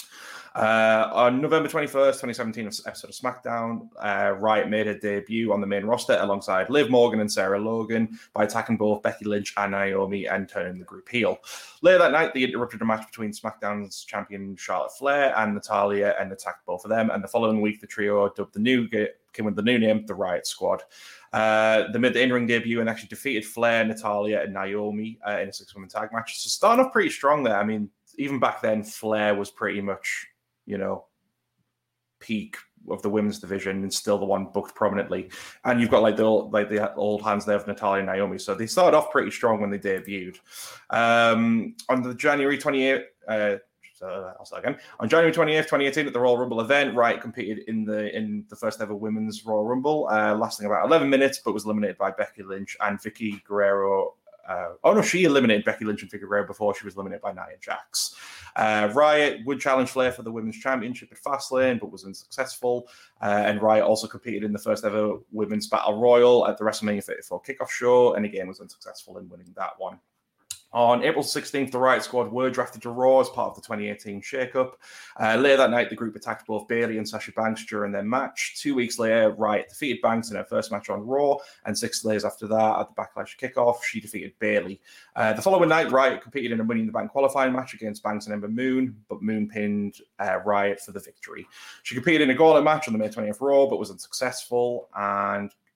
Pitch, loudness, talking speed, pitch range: 110 Hz, -24 LUFS, 215 wpm, 105-125 Hz